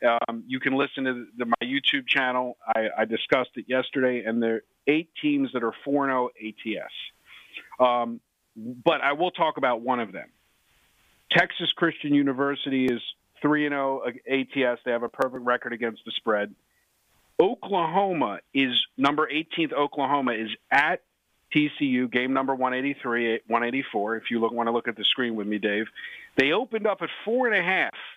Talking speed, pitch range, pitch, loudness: 175 wpm, 120-145 Hz, 130 Hz, -25 LUFS